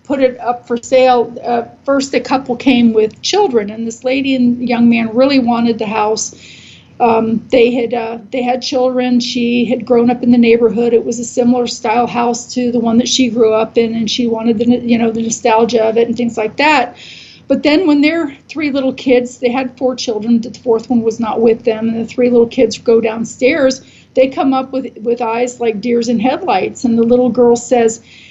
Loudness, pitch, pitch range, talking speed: -13 LUFS, 240 Hz, 230-255 Hz, 220 wpm